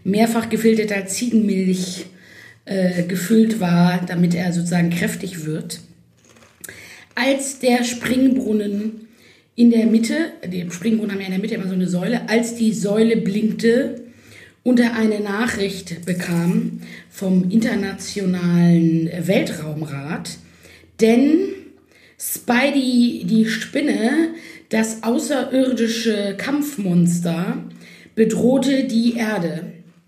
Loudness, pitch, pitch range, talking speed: -19 LUFS, 215 Hz, 180-240 Hz, 100 wpm